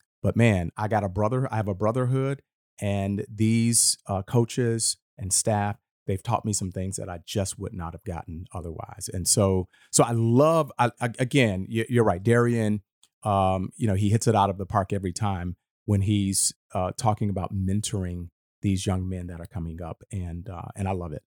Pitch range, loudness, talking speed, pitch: 95-115 Hz, -25 LUFS, 195 wpm, 100 Hz